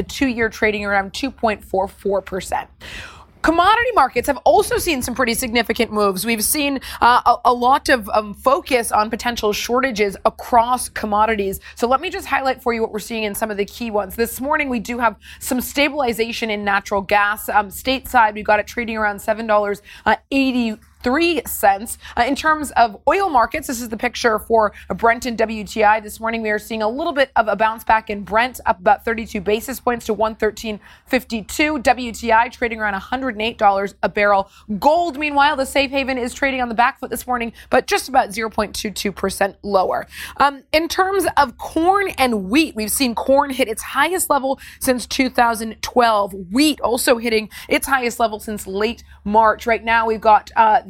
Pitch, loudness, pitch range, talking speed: 235 Hz, -18 LUFS, 215-265 Hz, 185 wpm